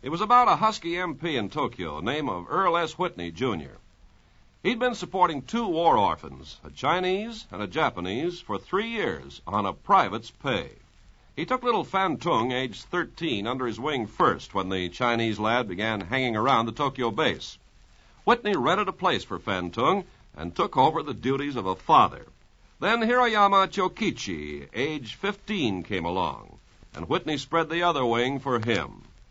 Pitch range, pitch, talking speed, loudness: 115-190 Hz, 145 Hz, 170 wpm, -26 LUFS